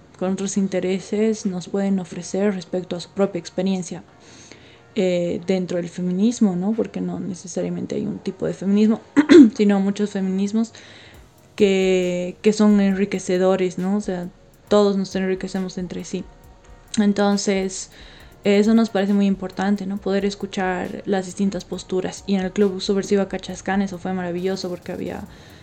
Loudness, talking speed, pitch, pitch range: -21 LUFS, 145 wpm, 190 Hz, 185-200 Hz